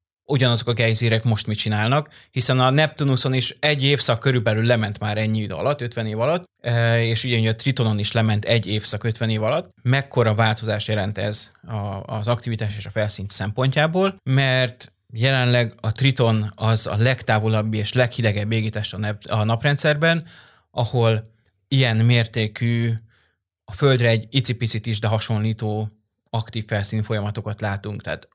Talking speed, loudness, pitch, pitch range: 145 wpm, -21 LUFS, 115 Hz, 110-125 Hz